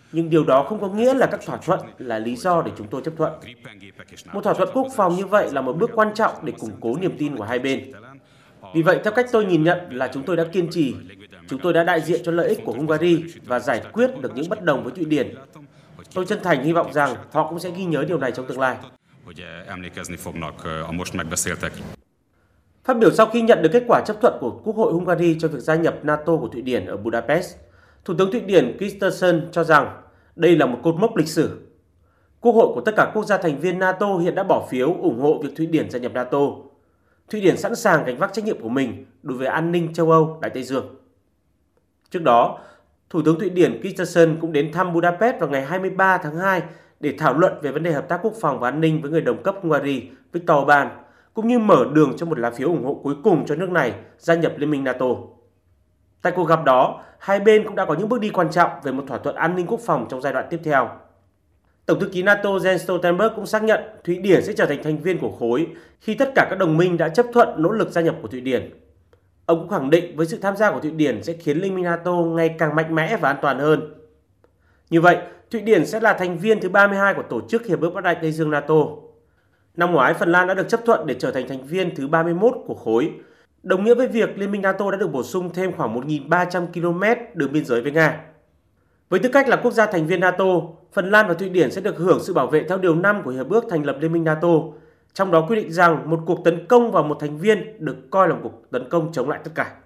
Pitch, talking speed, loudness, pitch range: 165 Hz, 250 wpm, -20 LUFS, 145-190 Hz